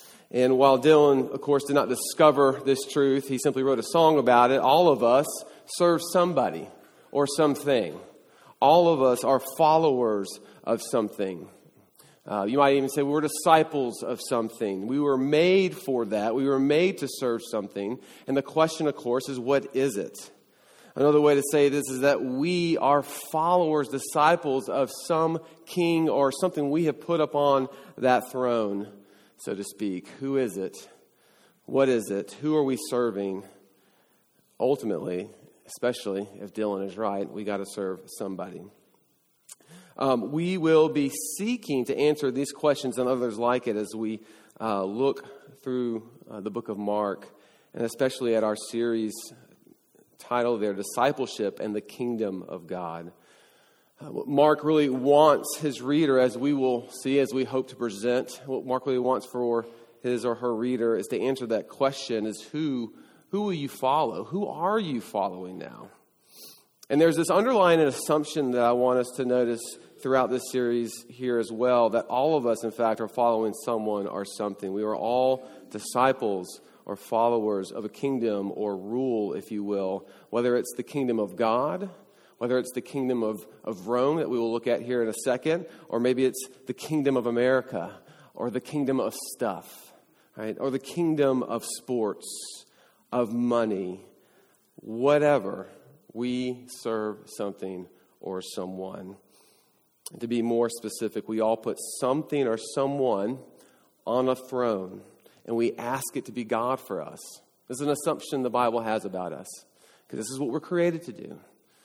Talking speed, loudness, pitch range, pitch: 170 wpm, -26 LUFS, 115-140 Hz, 125 Hz